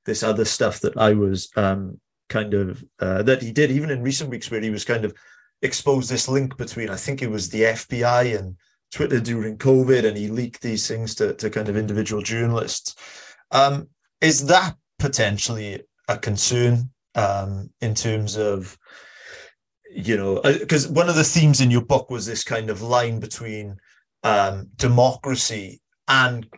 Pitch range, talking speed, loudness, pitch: 105-130 Hz, 170 wpm, -21 LUFS, 115 Hz